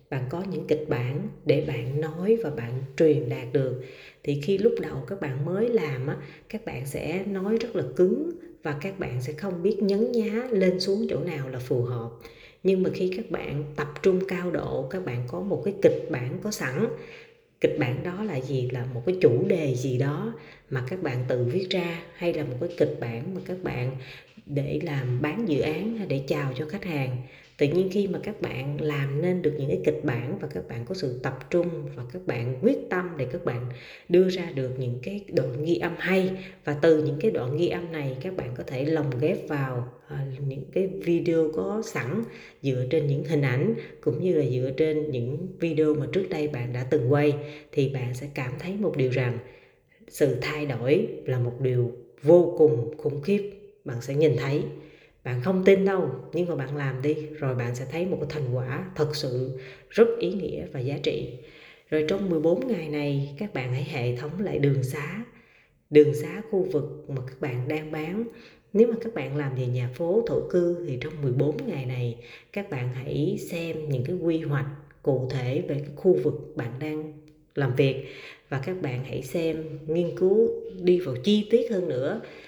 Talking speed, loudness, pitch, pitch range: 210 wpm, -27 LUFS, 155 Hz, 130-180 Hz